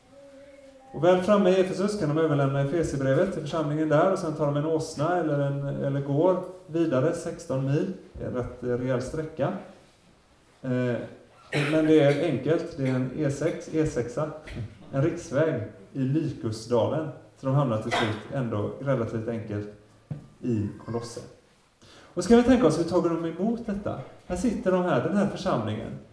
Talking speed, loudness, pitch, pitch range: 155 wpm, -26 LUFS, 150 Hz, 125-170 Hz